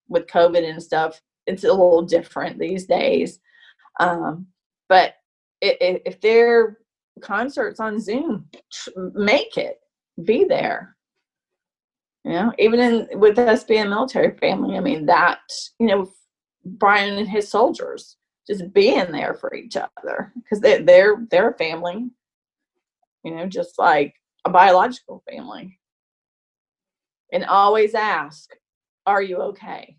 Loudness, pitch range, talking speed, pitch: -19 LUFS, 185-260 Hz, 135 wpm, 215 Hz